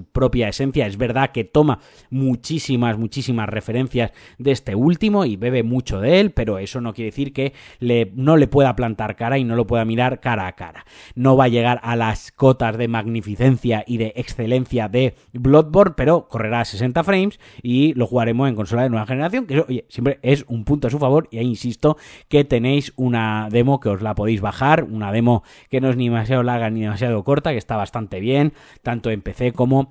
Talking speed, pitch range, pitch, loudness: 210 wpm, 115-135 Hz, 125 Hz, -19 LUFS